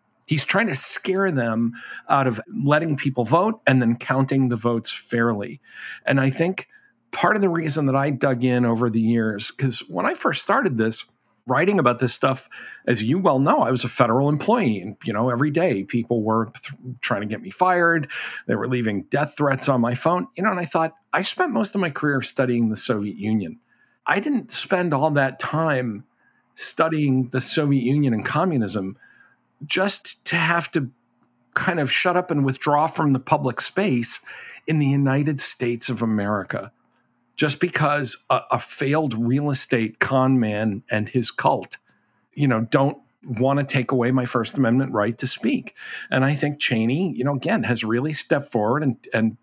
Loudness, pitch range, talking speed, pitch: -21 LUFS, 120-155 Hz, 190 wpm, 135 Hz